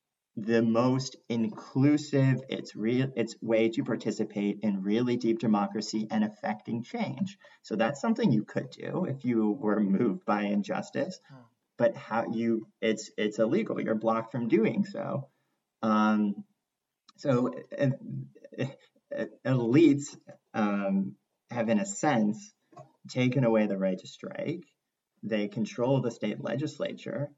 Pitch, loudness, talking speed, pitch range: 115 Hz, -29 LUFS, 130 wpm, 105-135 Hz